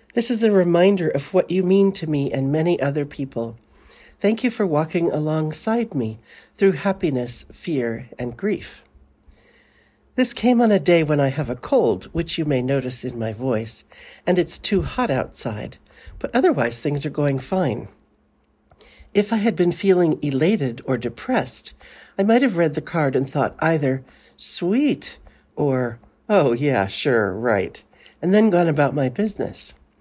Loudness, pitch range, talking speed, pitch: -21 LUFS, 130-195 Hz, 165 wpm, 155 Hz